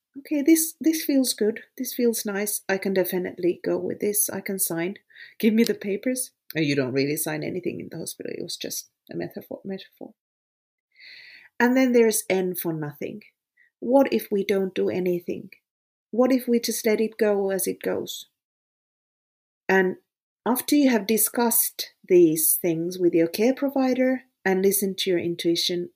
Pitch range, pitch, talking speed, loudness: 190-260 Hz, 220 Hz, 175 wpm, -23 LUFS